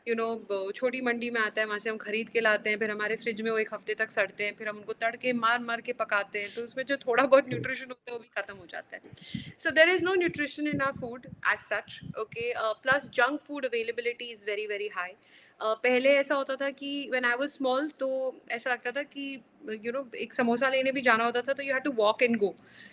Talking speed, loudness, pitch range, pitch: 255 wpm, -29 LUFS, 220-265 Hz, 240 Hz